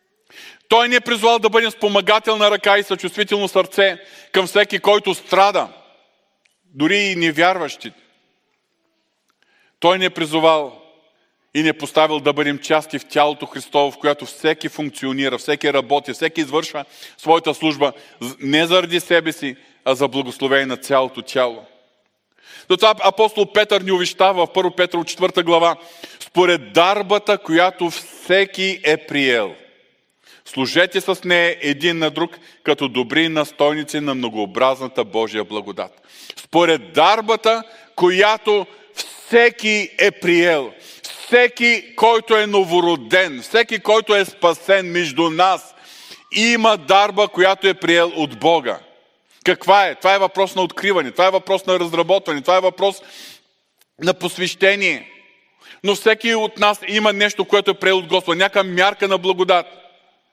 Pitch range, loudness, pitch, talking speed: 155-200 Hz, -17 LUFS, 180 Hz, 135 wpm